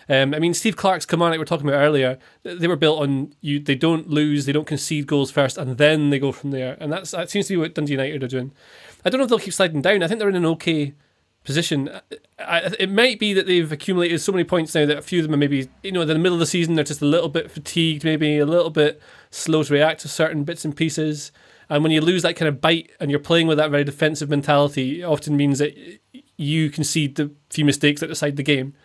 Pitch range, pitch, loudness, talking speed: 145-170 Hz, 155 Hz, -20 LUFS, 270 wpm